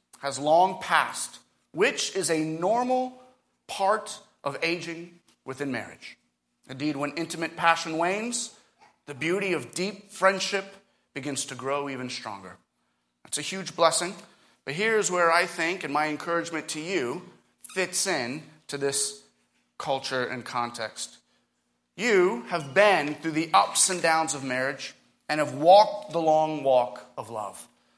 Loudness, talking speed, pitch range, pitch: -26 LUFS, 140 wpm, 135-185 Hz, 160 Hz